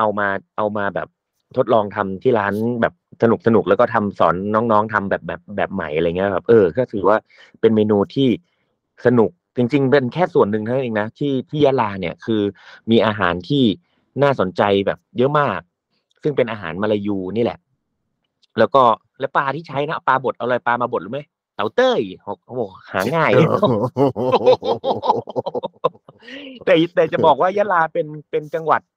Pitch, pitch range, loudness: 115 Hz, 105-145 Hz, -18 LUFS